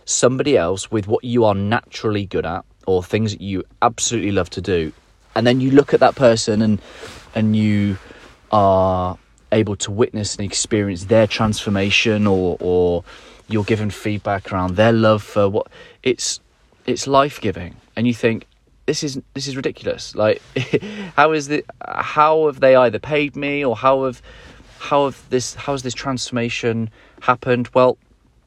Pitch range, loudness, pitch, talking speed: 105-135 Hz, -18 LUFS, 115 Hz, 165 wpm